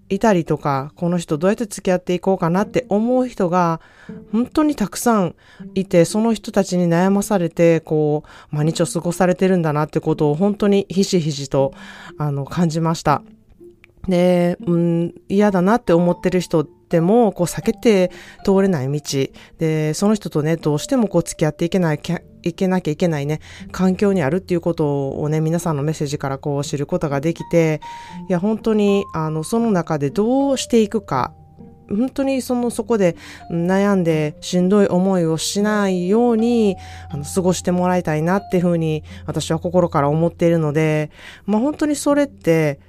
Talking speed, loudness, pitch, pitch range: 355 characters per minute, -19 LUFS, 180 Hz, 160-200 Hz